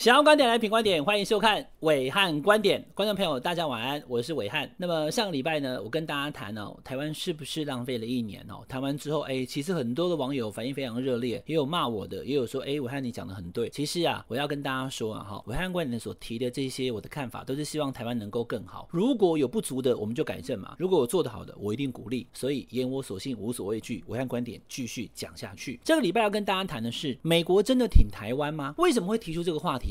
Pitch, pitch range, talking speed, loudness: 140 Hz, 125-170 Hz, 385 characters per minute, -28 LUFS